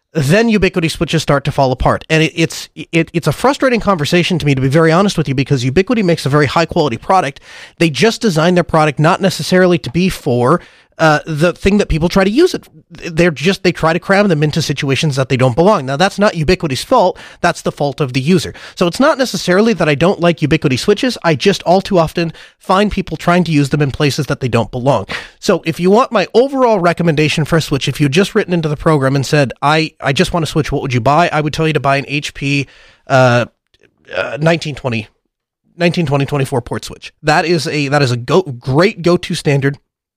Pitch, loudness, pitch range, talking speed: 160 Hz, -13 LUFS, 145-180 Hz, 235 wpm